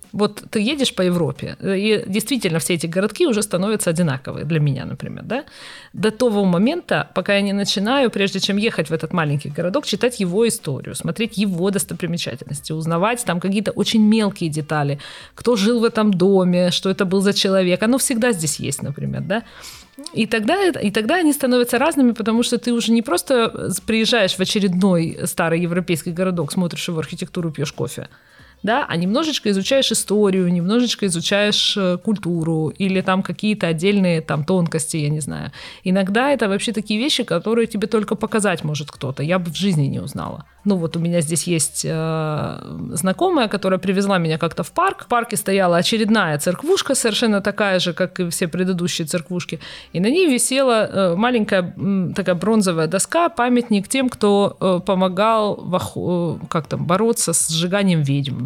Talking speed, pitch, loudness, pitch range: 175 wpm, 195 Hz, -19 LUFS, 170-225 Hz